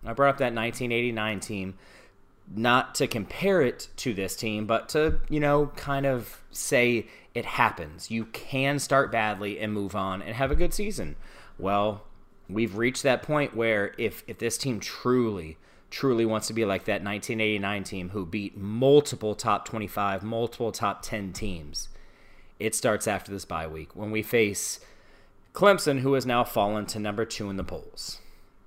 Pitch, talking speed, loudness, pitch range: 110 Hz, 170 wpm, -27 LUFS, 100-125 Hz